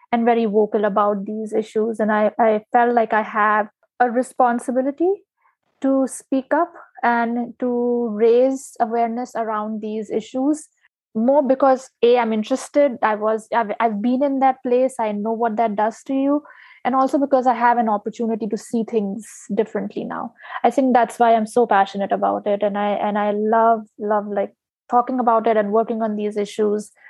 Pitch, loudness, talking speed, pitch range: 230 Hz, -20 LUFS, 180 wpm, 215-255 Hz